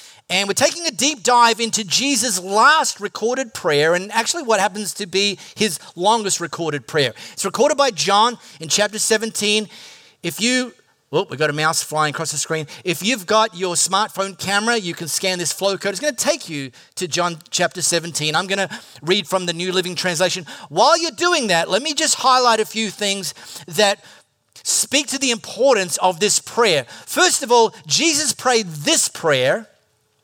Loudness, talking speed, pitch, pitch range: -18 LUFS, 190 wpm, 200 Hz, 175-235 Hz